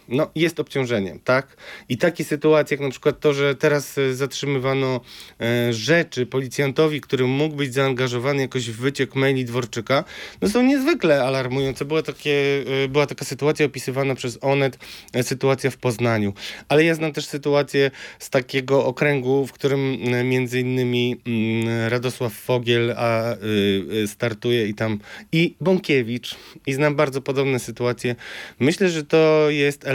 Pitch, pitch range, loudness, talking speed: 135 Hz, 125-145 Hz, -21 LUFS, 135 wpm